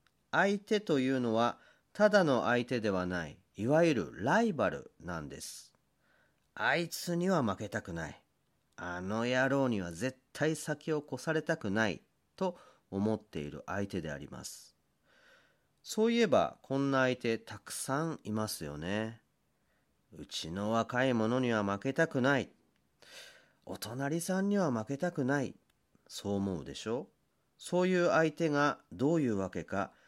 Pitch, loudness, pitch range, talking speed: 130 Hz, -33 LUFS, 100-160 Hz, 270 characters per minute